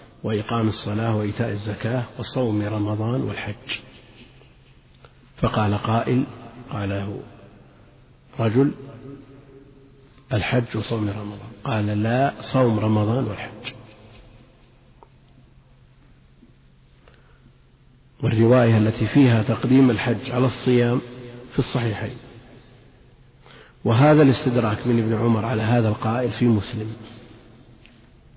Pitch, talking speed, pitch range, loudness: 120 Hz, 80 wpm, 110-130 Hz, -22 LUFS